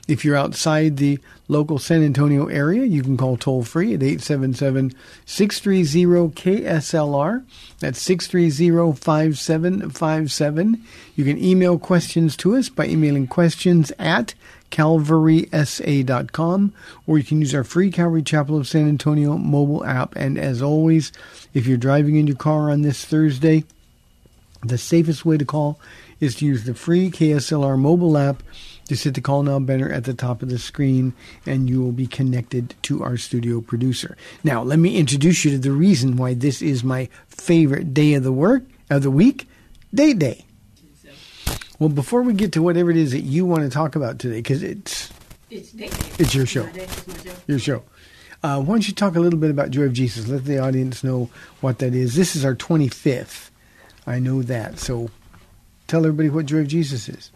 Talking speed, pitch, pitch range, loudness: 175 wpm, 150 Hz, 130-165 Hz, -19 LUFS